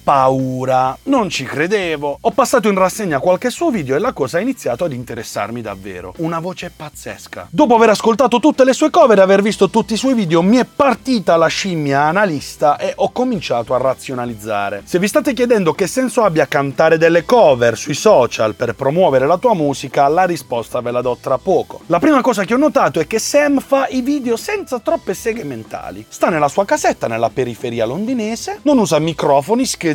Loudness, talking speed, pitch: -15 LUFS, 195 wpm, 185 Hz